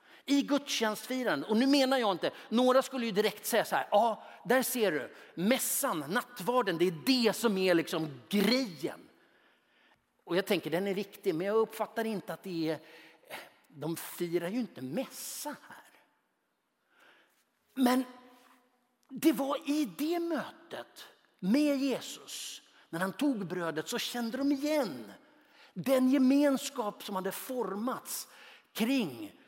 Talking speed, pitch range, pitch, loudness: 140 wpm, 195-265 Hz, 245 Hz, -31 LUFS